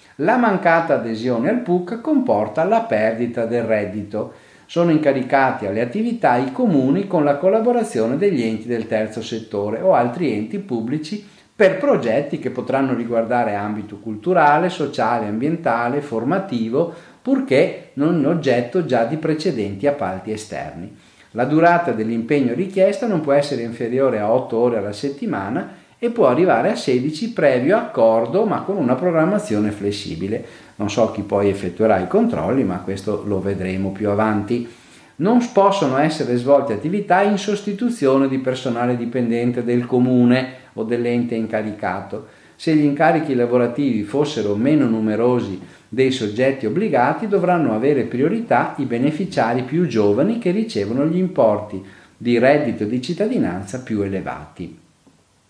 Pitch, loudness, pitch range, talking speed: 125 Hz, -19 LUFS, 110-165 Hz, 135 wpm